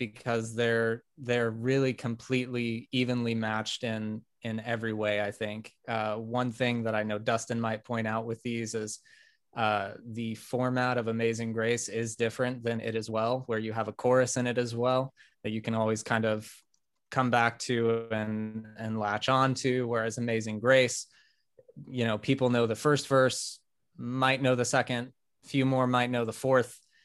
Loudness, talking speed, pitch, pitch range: -30 LUFS, 180 wpm, 115 Hz, 110-125 Hz